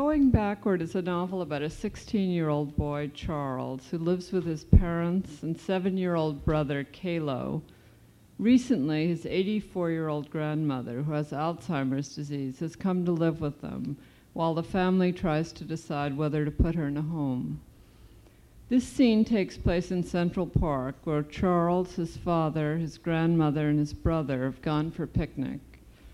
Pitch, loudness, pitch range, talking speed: 160 Hz, -29 LUFS, 150-180 Hz, 150 wpm